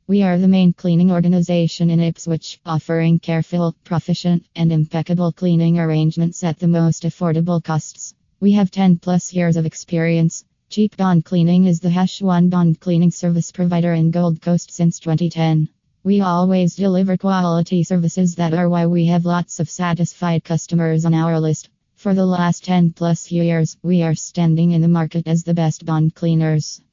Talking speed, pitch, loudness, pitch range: 170 wpm, 170 Hz, -17 LUFS, 165-175 Hz